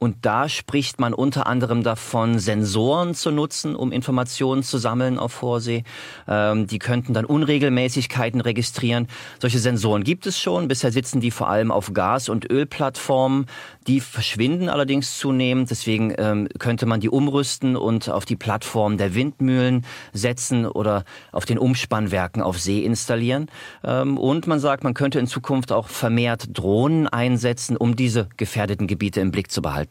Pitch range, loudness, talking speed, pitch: 110-135 Hz, -22 LUFS, 160 wpm, 120 Hz